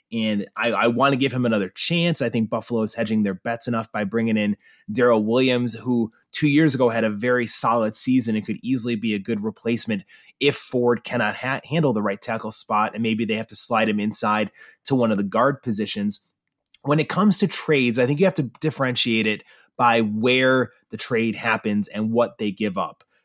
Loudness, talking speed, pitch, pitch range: -22 LUFS, 215 wpm, 115 Hz, 110-130 Hz